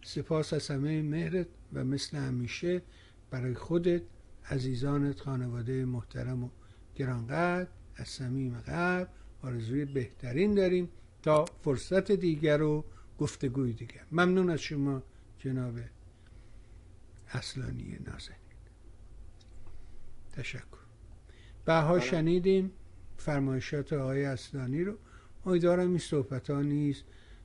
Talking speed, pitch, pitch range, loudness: 95 wpm, 130 Hz, 105-155 Hz, -32 LUFS